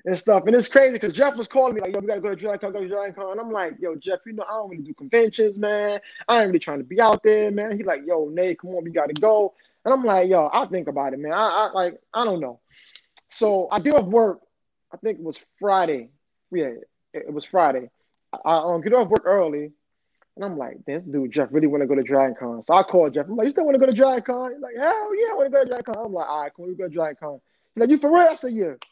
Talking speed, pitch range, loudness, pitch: 295 wpm, 170-235 Hz, -21 LUFS, 205 Hz